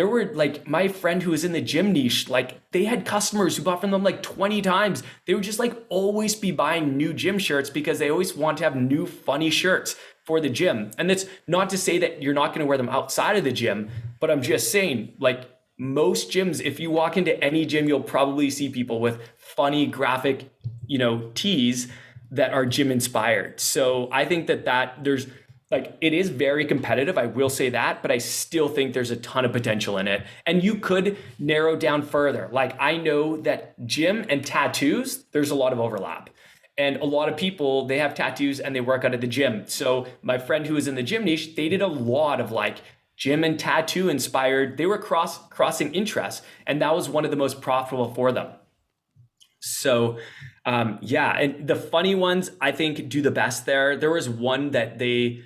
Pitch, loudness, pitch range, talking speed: 145 Hz, -23 LUFS, 125-165 Hz, 215 wpm